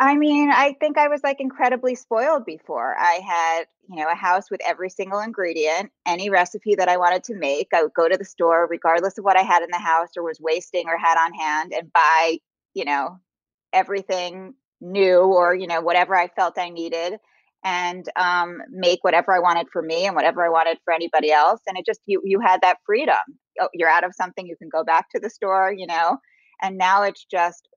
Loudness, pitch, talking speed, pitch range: -20 LUFS, 180 Hz, 220 wpm, 170-200 Hz